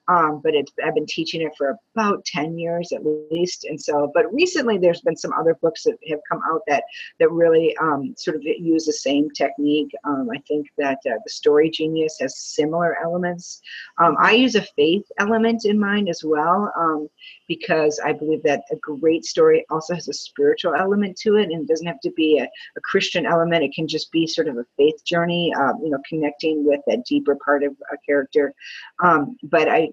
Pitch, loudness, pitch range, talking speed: 165 Hz, -20 LUFS, 150-210 Hz, 210 wpm